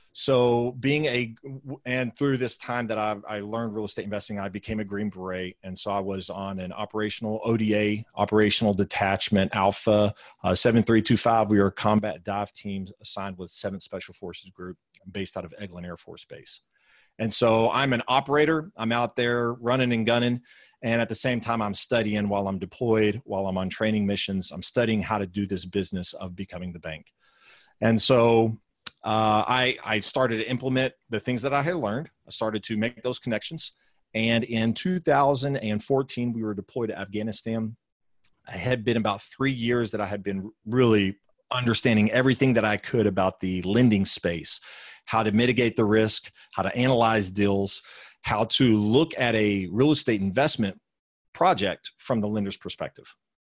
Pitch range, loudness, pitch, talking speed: 100-120 Hz, -25 LUFS, 110 Hz, 175 wpm